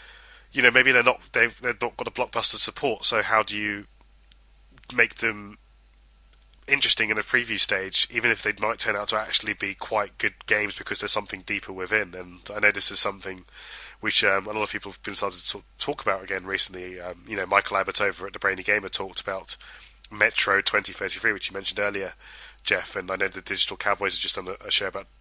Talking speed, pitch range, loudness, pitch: 215 wpm, 90-105 Hz, -23 LUFS, 95 Hz